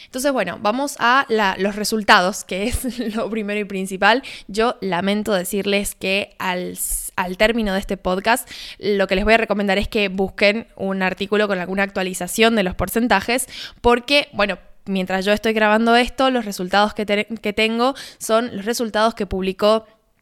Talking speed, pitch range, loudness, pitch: 170 wpm, 195-225 Hz, -19 LUFS, 210 Hz